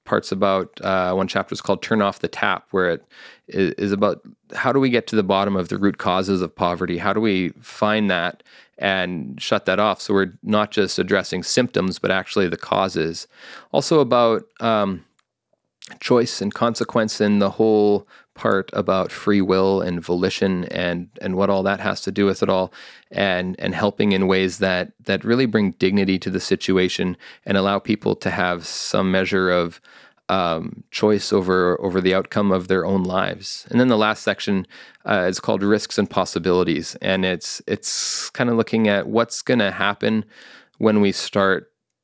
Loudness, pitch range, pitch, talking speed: -20 LUFS, 95-105 Hz, 95 Hz, 185 wpm